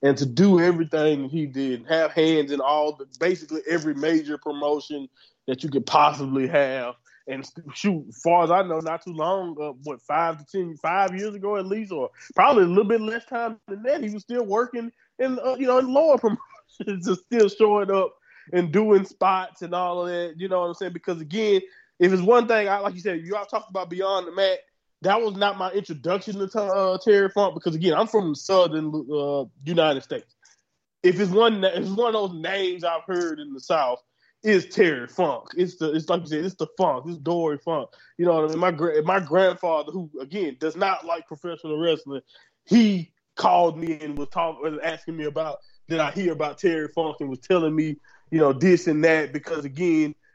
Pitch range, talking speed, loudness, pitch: 155-195 Hz, 215 wpm, -23 LUFS, 175 Hz